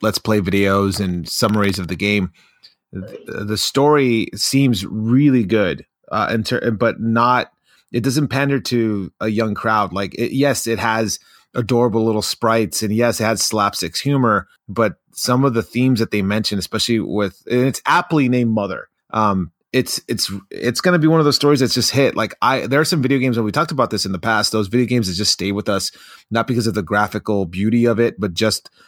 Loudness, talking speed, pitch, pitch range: -18 LUFS, 210 wpm, 115 Hz, 105-125 Hz